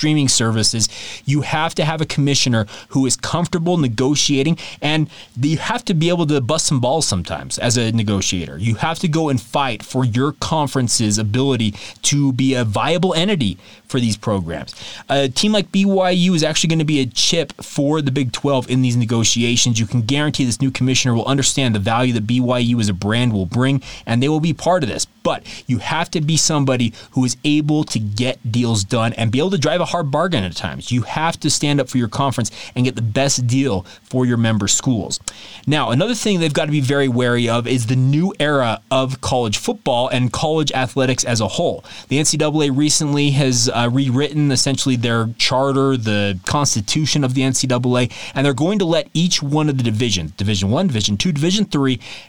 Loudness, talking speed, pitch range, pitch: -17 LUFS, 205 wpm, 115-150 Hz, 130 Hz